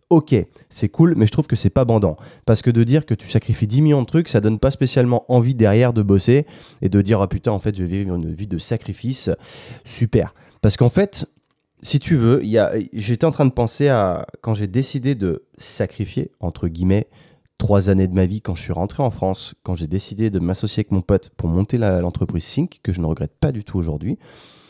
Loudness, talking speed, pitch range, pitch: -19 LUFS, 240 wpm, 95-130 Hz, 110 Hz